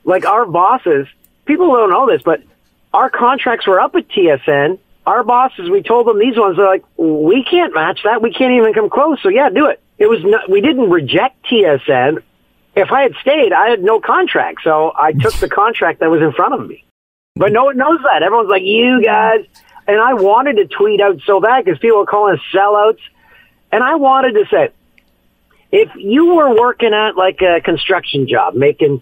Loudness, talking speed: -12 LUFS, 205 wpm